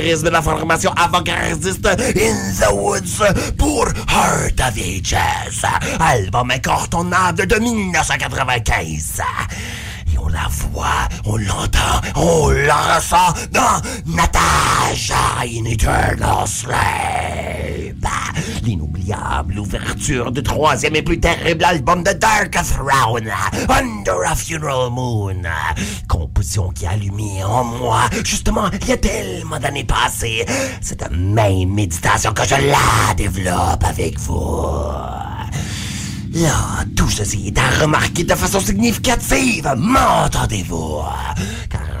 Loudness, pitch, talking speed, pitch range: -17 LUFS, 105 Hz, 105 wpm, 95-135 Hz